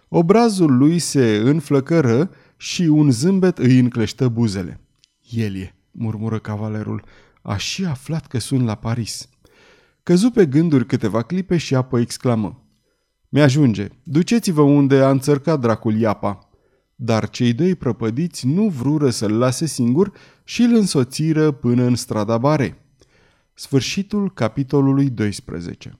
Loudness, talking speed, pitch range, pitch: -18 LUFS, 125 wpm, 115-155 Hz, 130 Hz